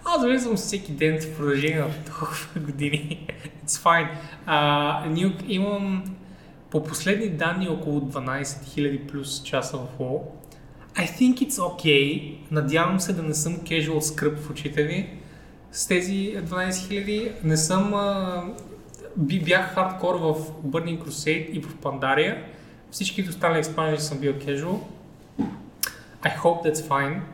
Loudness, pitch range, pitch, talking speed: -25 LUFS, 150-185 Hz, 160 Hz, 140 wpm